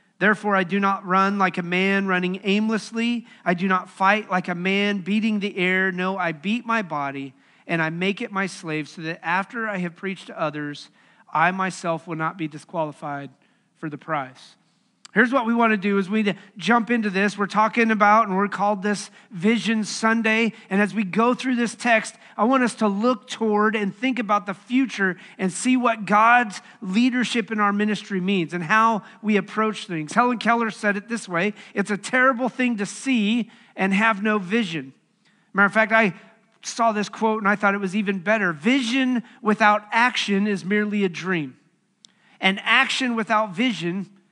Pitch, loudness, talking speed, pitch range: 205 Hz, -22 LUFS, 195 wpm, 190-225 Hz